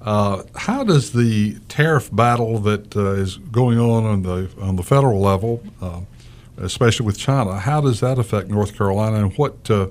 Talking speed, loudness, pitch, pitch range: 180 wpm, -19 LUFS, 110 Hz, 100-120 Hz